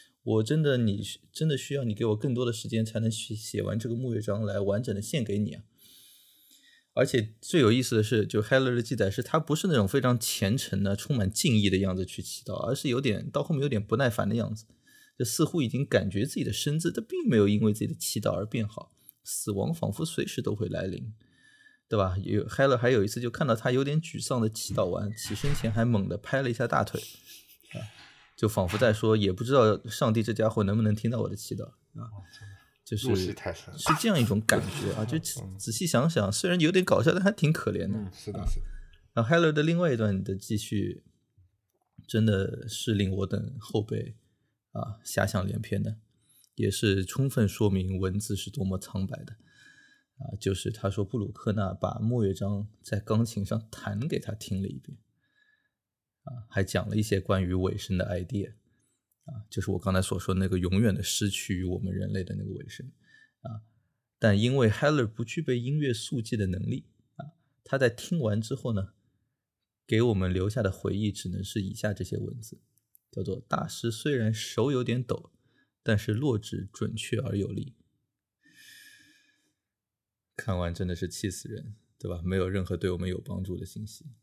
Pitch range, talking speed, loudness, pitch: 100-125 Hz, 295 characters per minute, -29 LUFS, 110 Hz